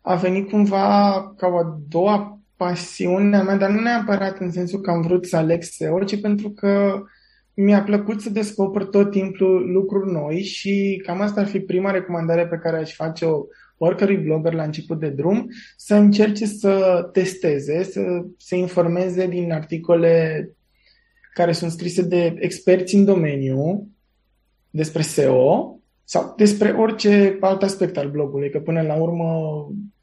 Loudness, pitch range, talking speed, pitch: -20 LUFS, 170-200 Hz, 160 wpm, 185 Hz